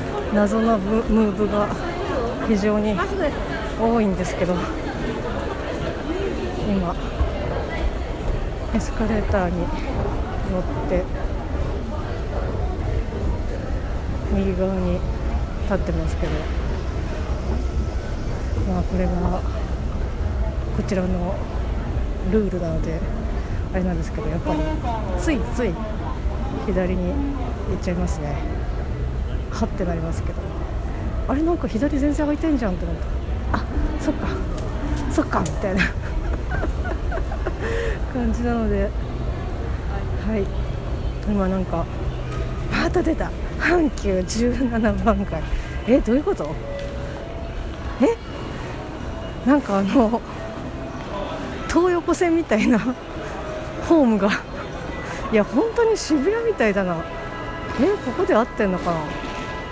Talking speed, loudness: 190 characters per minute, -24 LUFS